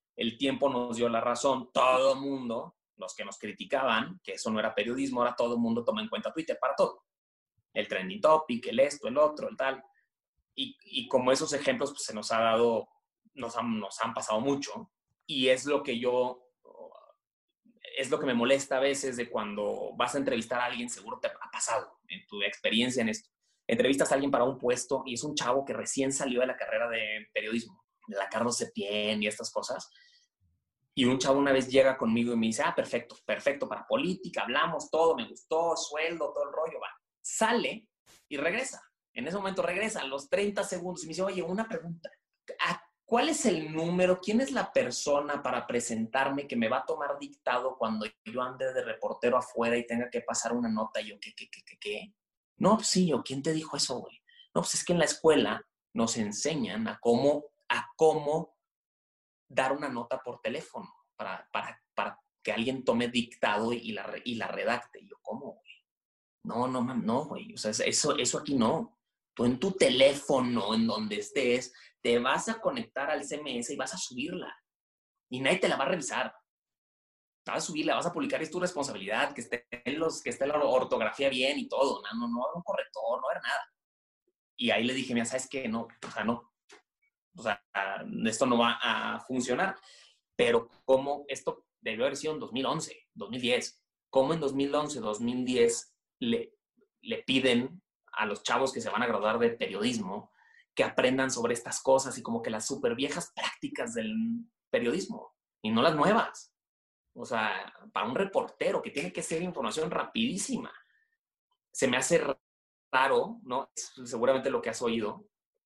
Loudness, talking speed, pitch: -30 LUFS, 195 wpm, 145 Hz